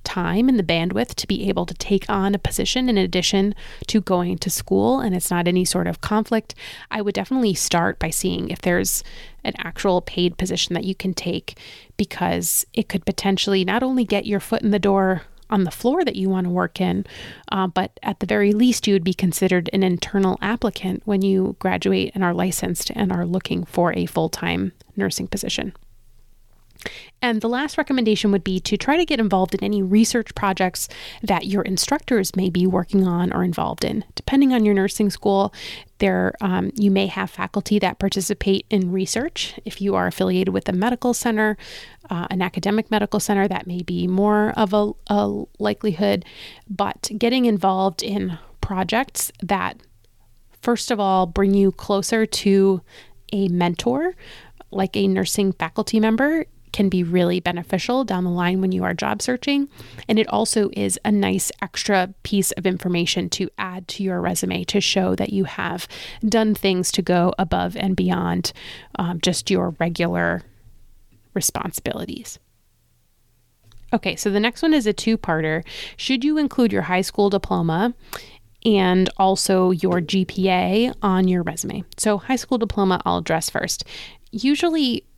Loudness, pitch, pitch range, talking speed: -21 LUFS, 195 Hz, 180-215 Hz, 175 wpm